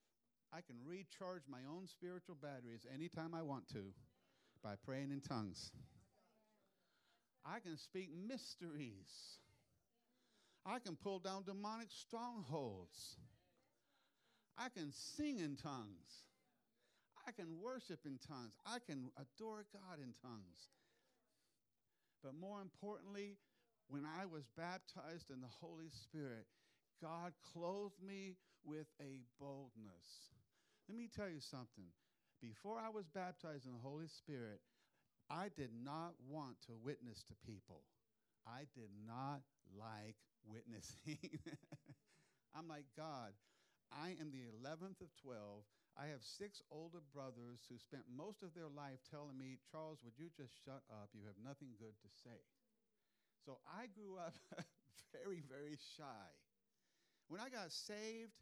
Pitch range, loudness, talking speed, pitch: 120-180 Hz, -54 LUFS, 130 wpm, 150 Hz